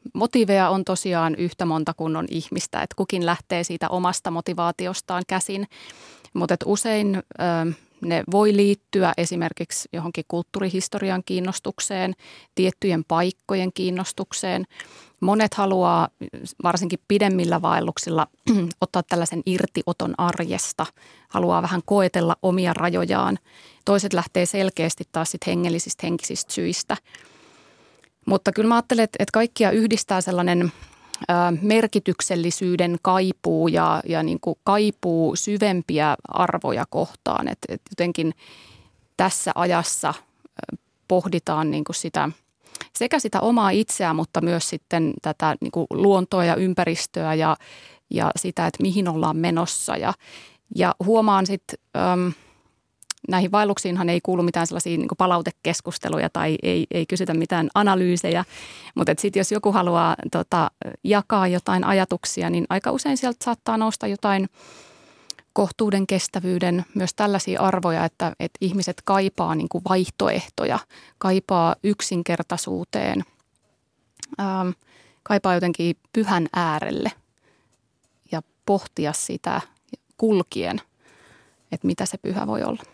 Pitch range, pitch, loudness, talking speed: 170-200 Hz, 185 Hz, -23 LUFS, 115 wpm